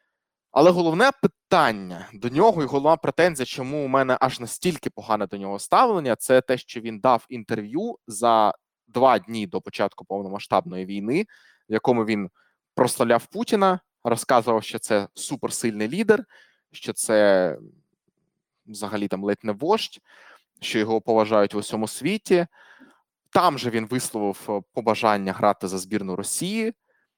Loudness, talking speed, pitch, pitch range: -23 LUFS, 135 wpm, 115 Hz, 105-170 Hz